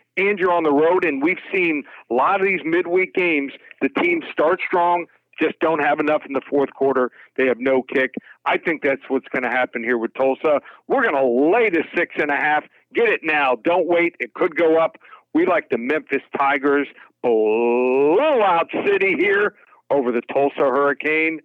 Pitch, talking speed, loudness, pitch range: 155 Hz, 200 wpm, -19 LUFS, 135-180 Hz